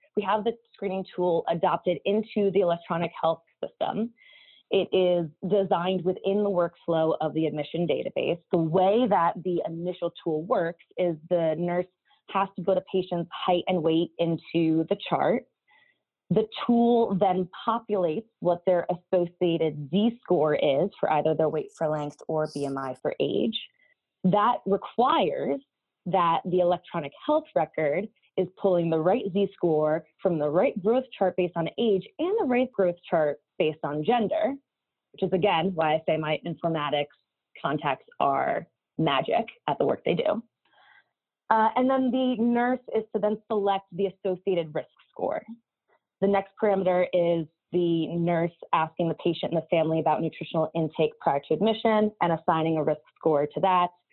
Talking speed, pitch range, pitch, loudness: 160 wpm, 165-210 Hz, 180 Hz, -26 LUFS